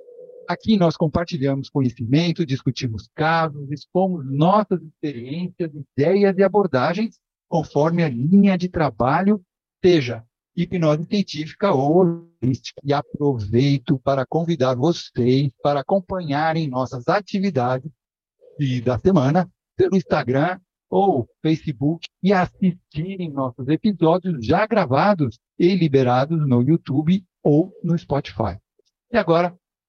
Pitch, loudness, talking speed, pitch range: 160 Hz, -21 LUFS, 105 wpm, 140-185 Hz